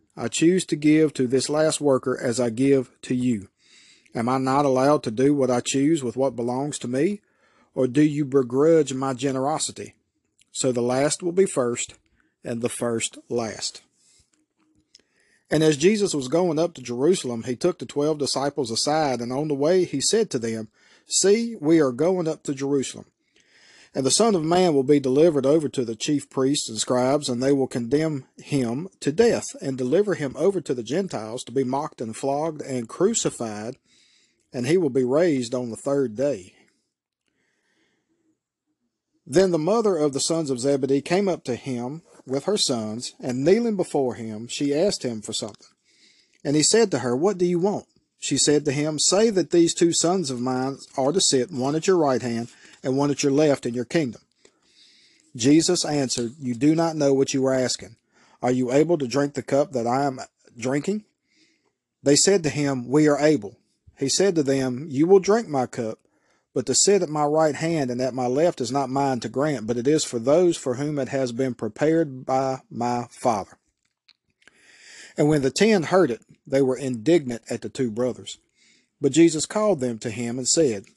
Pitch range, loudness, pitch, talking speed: 125-160 Hz, -22 LUFS, 140 Hz, 195 wpm